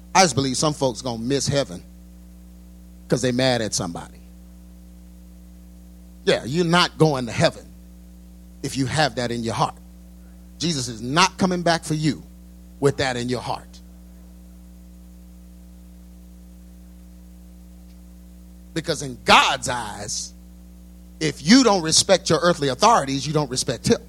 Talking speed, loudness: 130 wpm, -21 LUFS